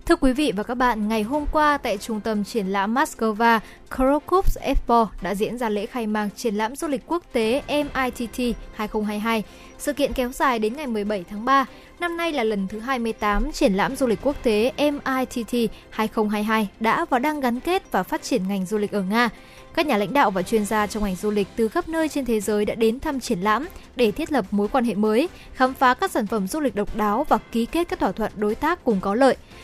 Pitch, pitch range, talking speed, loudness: 235 Hz, 215-275 Hz, 235 wpm, -23 LUFS